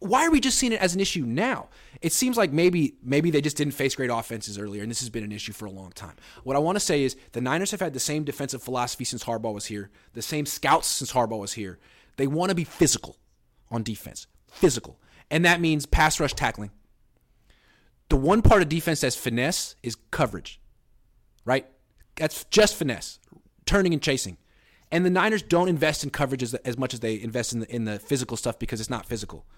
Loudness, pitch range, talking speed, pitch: -25 LUFS, 115-160 Hz, 220 wpm, 130 Hz